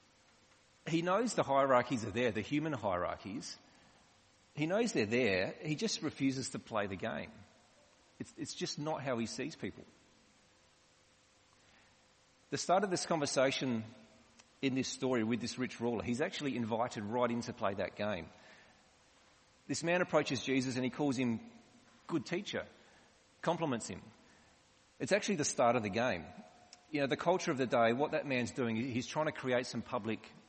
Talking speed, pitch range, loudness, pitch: 165 wpm, 120-155 Hz, -36 LUFS, 130 Hz